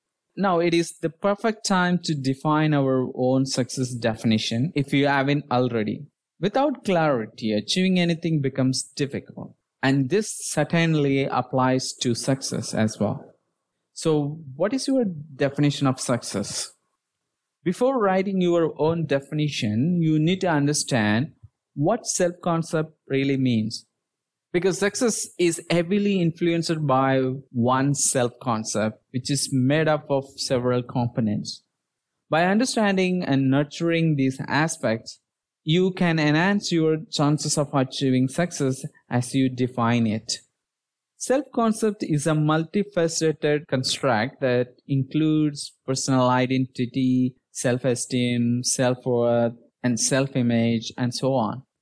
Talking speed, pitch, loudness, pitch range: 120 wpm, 140 Hz, -23 LUFS, 125-170 Hz